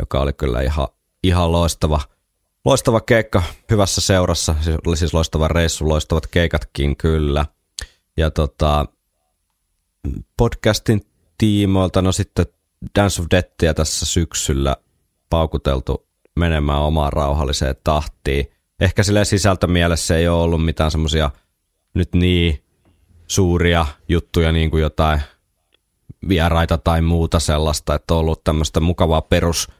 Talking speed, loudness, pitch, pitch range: 120 wpm, -18 LUFS, 80 Hz, 75-90 Hz